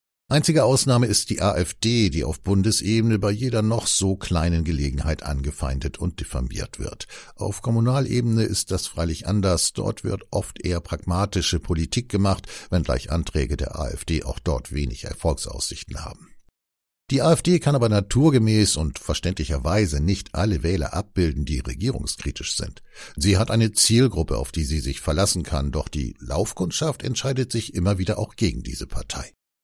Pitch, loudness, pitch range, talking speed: 95 Hz, -23 LUFS, 80-110 Hz, 150 wpm